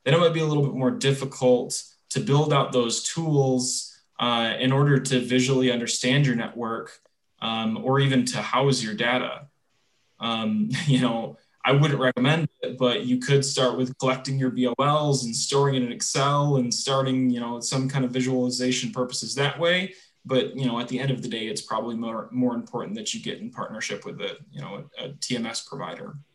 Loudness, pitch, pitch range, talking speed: -24 LUFS, 130 Hz, 125-140 Hz, 200 wpm